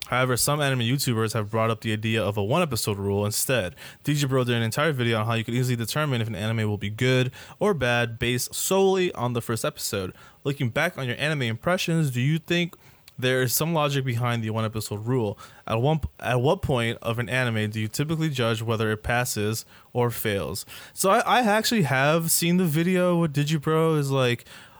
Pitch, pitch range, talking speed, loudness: 125 Hz, 115-150 Hz, 210 wpm, -24 LUFS